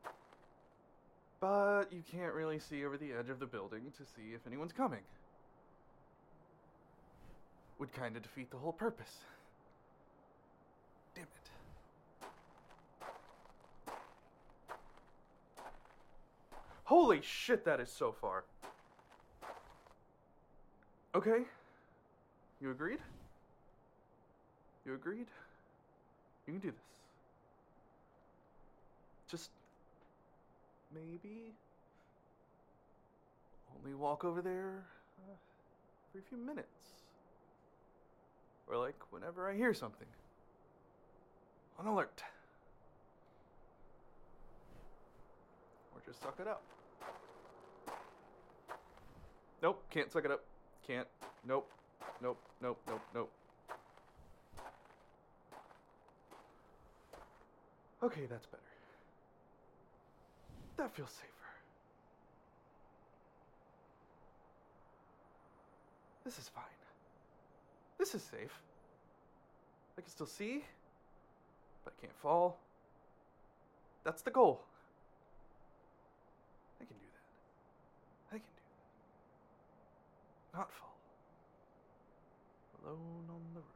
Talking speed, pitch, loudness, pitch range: 80 wpm, 175 Hz, -41 LUFS, 145-215 Hz